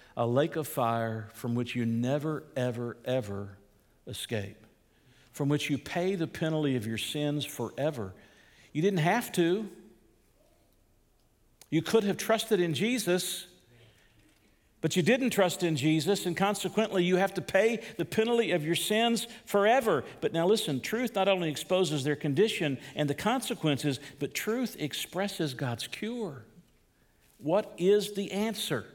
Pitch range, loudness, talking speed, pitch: 125-200 Hz, -30 LUFS, 145 wpm, 160 Hz